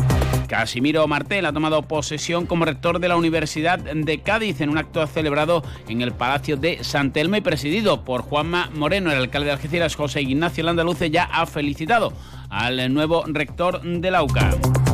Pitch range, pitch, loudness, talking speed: 145-170 Hz, 155 Hz, -21 LUFS, 170 wpm